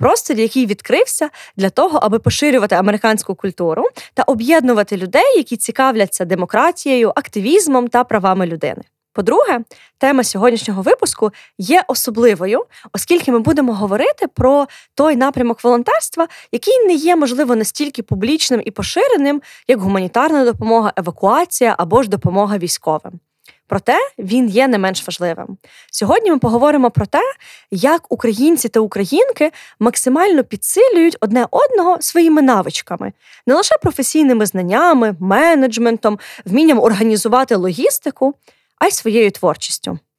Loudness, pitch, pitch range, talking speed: -14 LUFS, 245 Hz, 210-310 Hz, 120 wpm